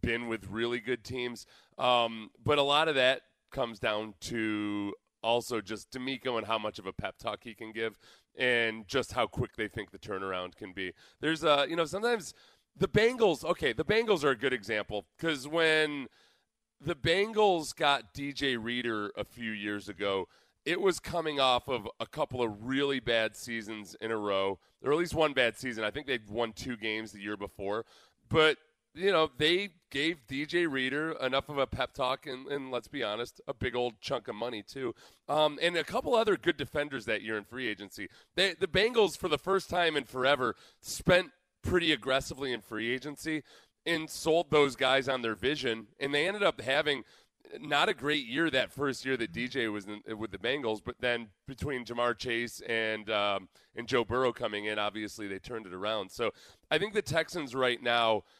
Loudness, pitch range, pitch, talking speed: -31 LUFS, 110-155 Hz, 125 Hz, 200 wpm